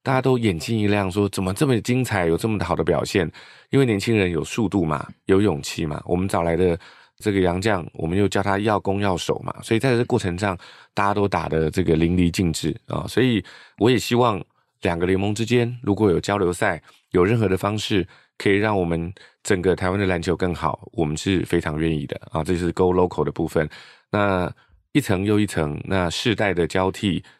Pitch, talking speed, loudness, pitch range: 95 Hz, 320 characters per minute, -22 LUFS, 85-105 Hz